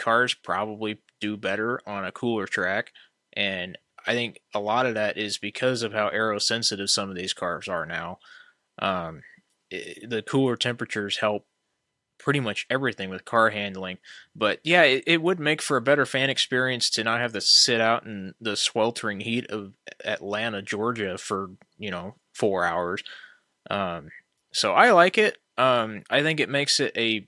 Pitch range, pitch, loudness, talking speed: 105-130 Hz, 115 Hz, -24 LUFS, 175 wpm